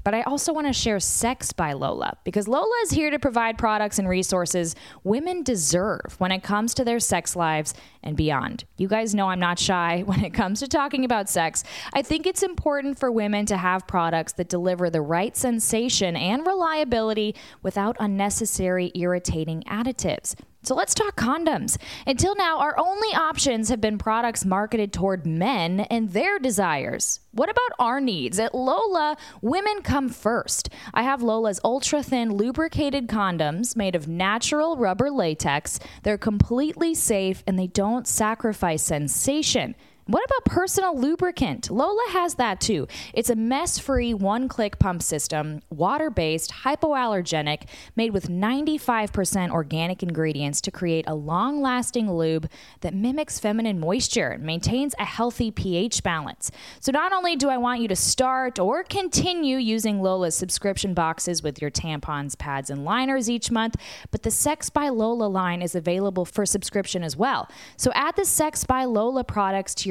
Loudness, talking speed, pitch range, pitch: -24 LUFS, 165 wpm, 185-260 Hz, 215 Hz